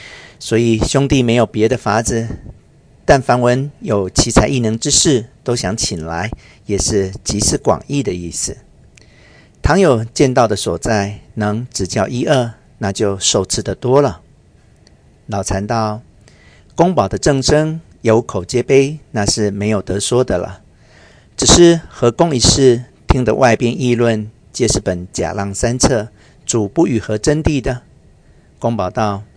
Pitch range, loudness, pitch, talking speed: 100-130 Hz, -15 LUFS, 115 Hz, 205 characters per minute